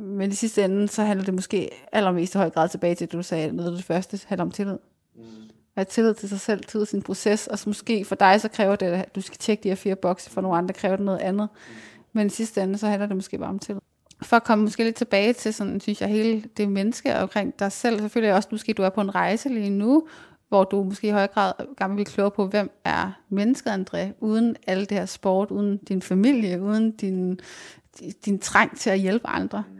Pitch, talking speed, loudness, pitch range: 200 Hz, 255 wpm, -24 LUFS, 190-215 Hz